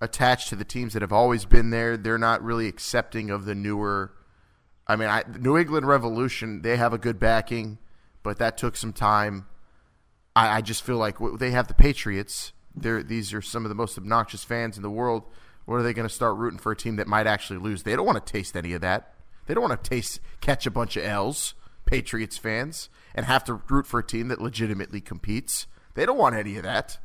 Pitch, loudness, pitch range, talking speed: 115 Hz, -26 LUFS, 105-120 Hz, 230 wpm